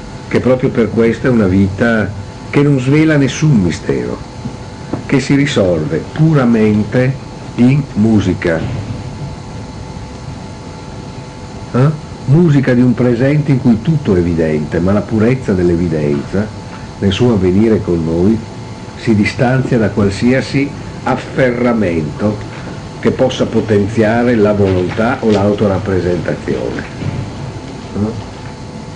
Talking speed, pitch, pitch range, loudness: 105 wpm, 120 Hz, 100-125 Hz, -13 LUFS